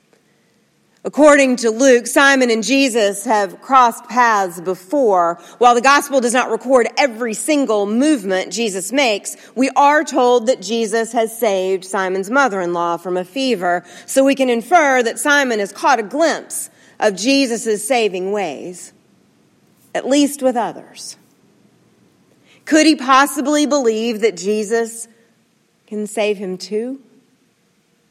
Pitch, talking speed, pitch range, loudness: 230 Hz, 135 wpm, 210-270 Hz, -16 LUFS